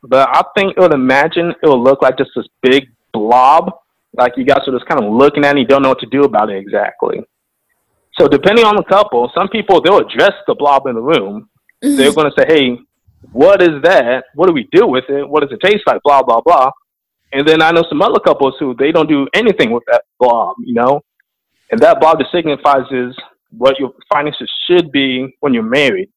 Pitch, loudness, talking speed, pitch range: 145 Hz, -11 LUFS, 225 wpm, 130-190 Hz